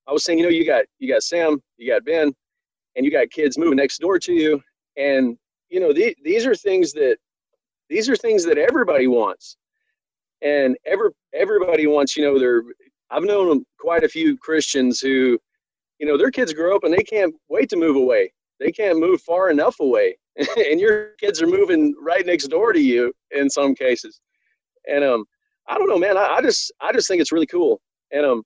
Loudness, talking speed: -19 LUFS, 210 wpm